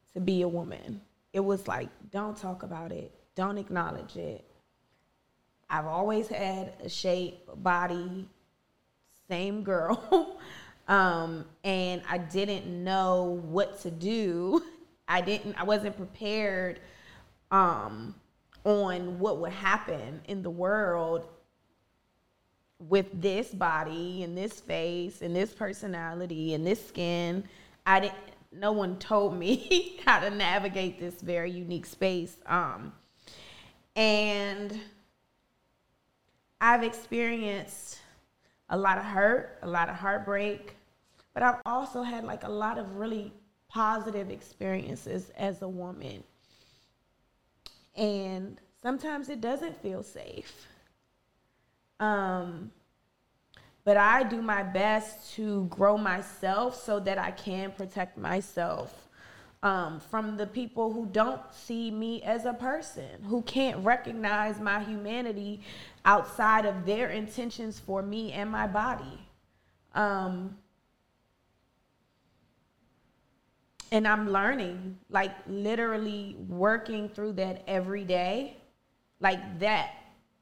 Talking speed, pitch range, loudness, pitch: 115 wpm, 185-215 Hz, -30 LUFS, 200 Hz